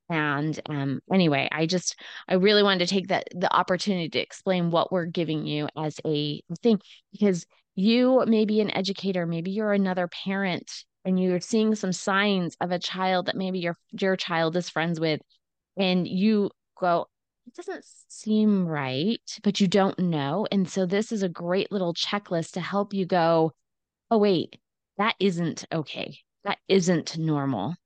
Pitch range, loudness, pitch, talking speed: 165-200 Hz, -25 LUFS, 185 Hz, 170 wpm